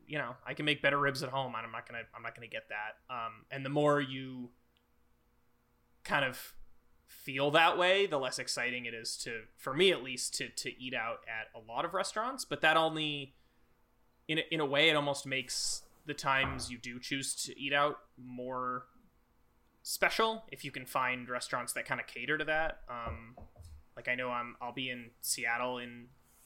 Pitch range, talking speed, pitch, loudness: 120-145 Hz, 195 wpm, 130 Hz, -34 LUFS